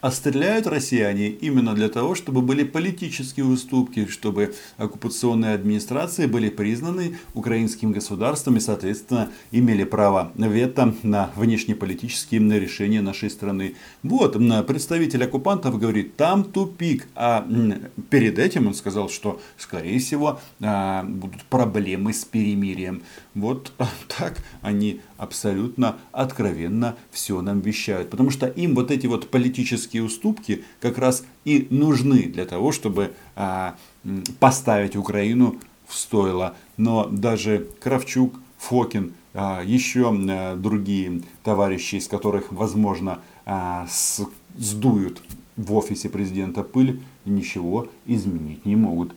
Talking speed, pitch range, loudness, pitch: 115 wpm, 100-130 Hz, -23 LUFS, 110 Hz